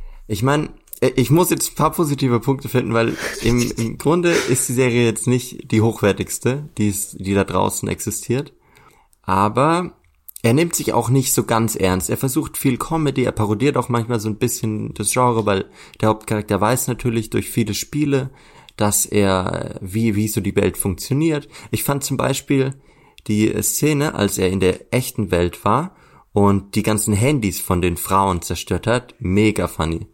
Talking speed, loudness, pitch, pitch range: 175 wpm, -19 LUFS, 115 Hz, 100-135 Hz